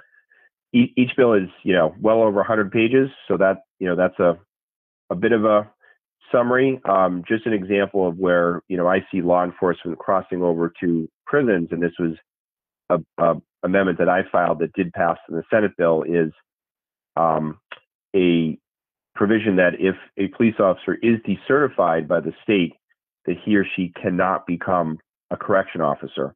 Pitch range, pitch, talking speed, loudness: 85-110 Hz, 95 Hz, 170 wpm, -20 LUFS